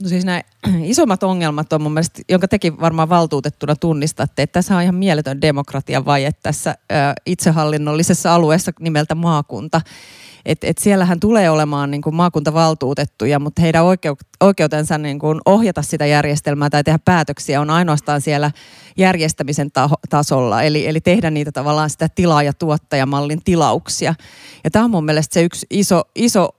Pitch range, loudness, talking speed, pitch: 150-175 Hz, -16 LUFS, 160 wpm, 155 Hz